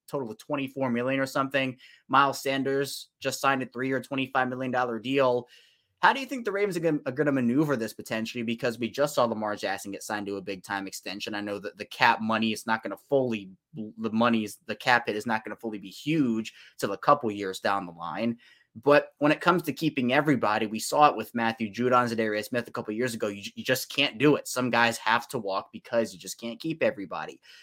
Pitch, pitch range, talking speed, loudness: 120 Hz, 110-135 Hz, 235 wpm, -27 LUFS